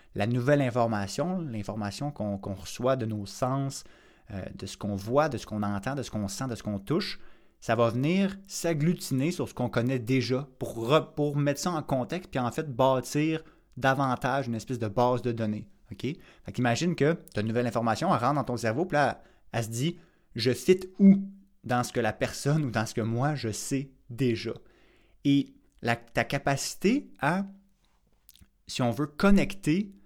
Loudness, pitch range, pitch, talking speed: -29 LUFS, 115-150 Hz, 130 Hz, 200 wpm